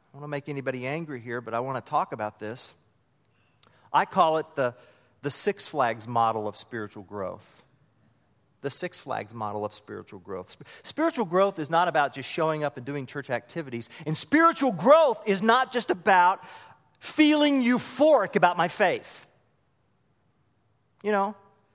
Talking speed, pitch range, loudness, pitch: 165 wpm, 120-195 Hz, -26 LUFS, 140 Hz